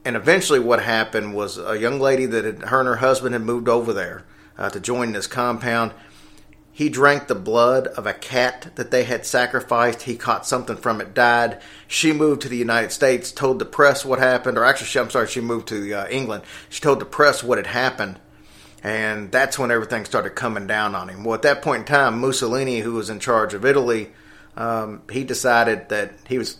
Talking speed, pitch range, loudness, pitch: 215 wpm, 110-130 Hz, -20 LUFS, 120 Hz